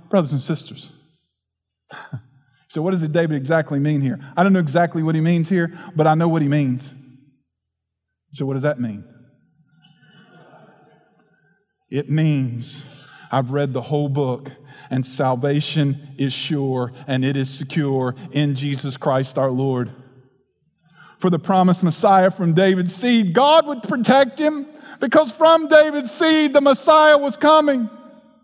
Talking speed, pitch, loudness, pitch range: 145 wpm, 155 Hz, -18 LUFS, 135-190 Hz